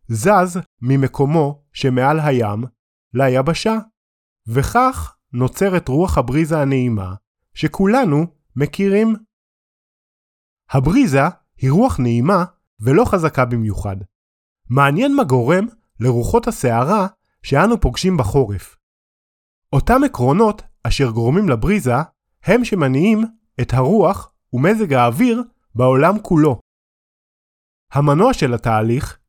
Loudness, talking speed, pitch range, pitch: -17 LUFS, 90 wpm, 125-205 Hz, 145 Hz